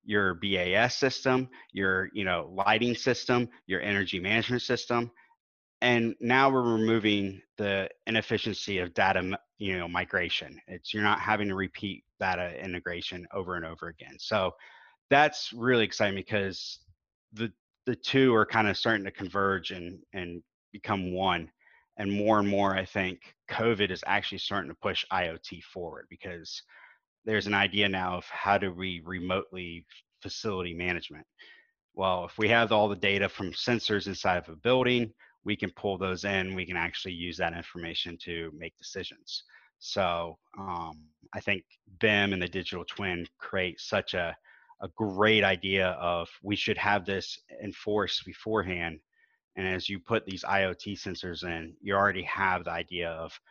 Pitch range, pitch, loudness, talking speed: 90-110 Hz, 95 Hz, -29 LUFS, 160 wpm